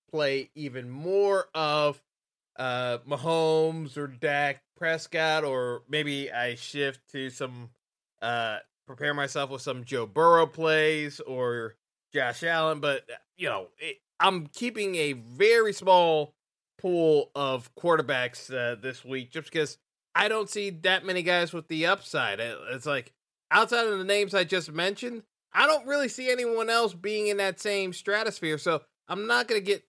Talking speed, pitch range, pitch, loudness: 155 wpm, 140-195 Hz, 160 Hz, -27 LUFS